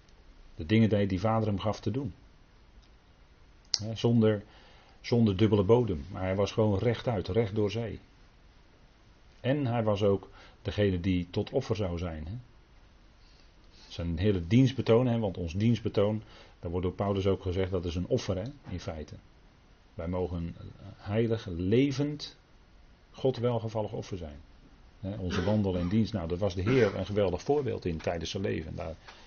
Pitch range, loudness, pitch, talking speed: 90-110 Hz, -30 LUFS, 100 Hz, 155 wpm